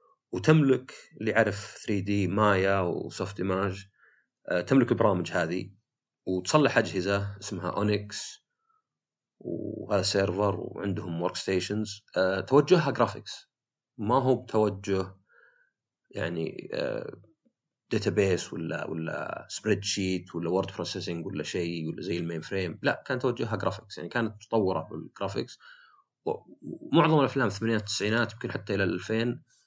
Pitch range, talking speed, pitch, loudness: 95-120 Hz, 115 wpm, 105 Hz, -29 LUFS